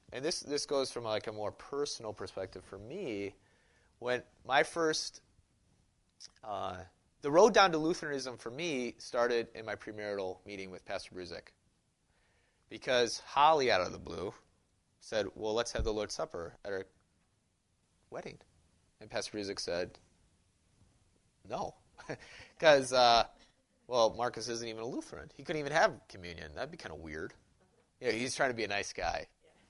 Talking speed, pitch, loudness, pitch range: 160 wpm, 110 Hz, -33 LUFS, 95-125 Hz